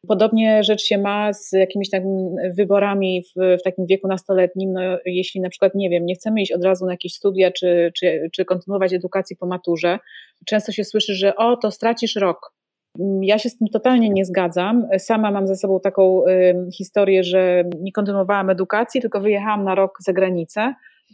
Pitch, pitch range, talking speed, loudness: 195 Hz, 185-210 Hz, 185 wpm, -19 LUFS